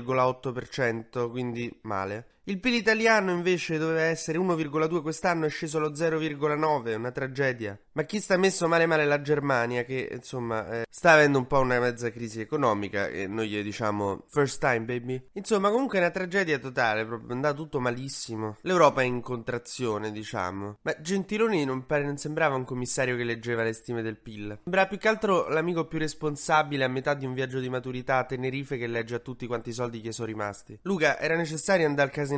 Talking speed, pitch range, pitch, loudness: 190 wpm, 120-160 Hz, 130 Hz, -27 LUFS